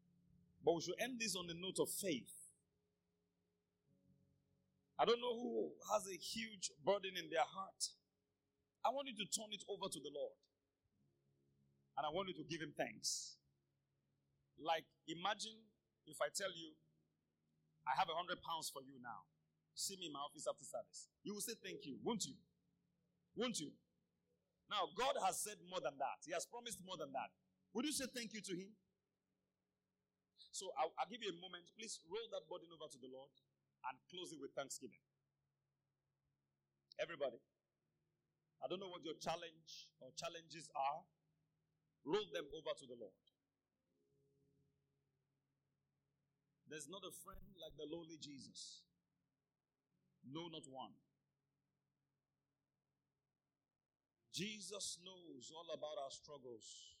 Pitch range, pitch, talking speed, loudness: 130-190 Hz, 155 Hz, 150 wpm, -47 LUFS